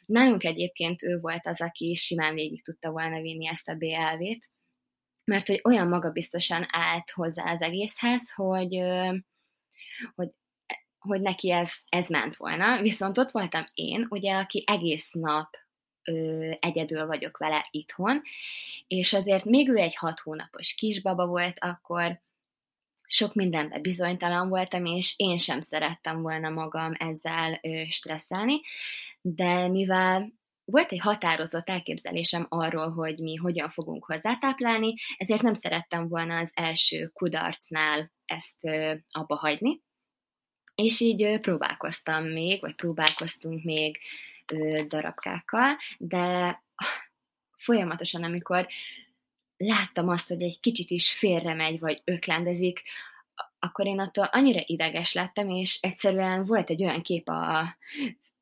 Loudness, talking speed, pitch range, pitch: -27 LUFS, 120 wpm, 160-200 Hz, 175 Hz